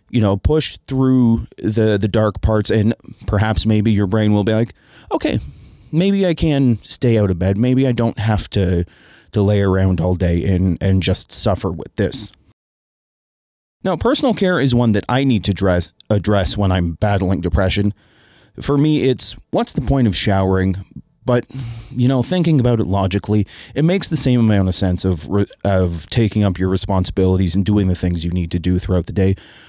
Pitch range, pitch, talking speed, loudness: 95-120 Hz, 105 Hz, 190 wpm, -17 LUFS